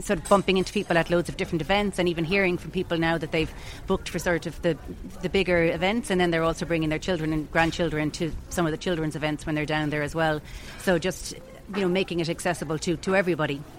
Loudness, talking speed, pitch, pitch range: -26 LUFS, 250 wpm, 170 Hz, 160-185 Hz